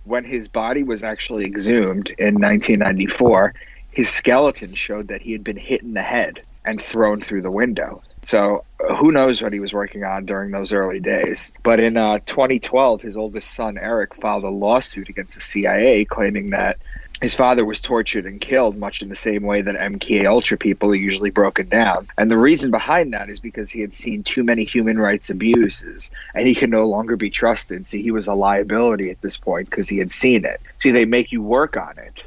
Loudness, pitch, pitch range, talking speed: -18 LUFS, 110 Hz, 100-120 Hz, 210 wpm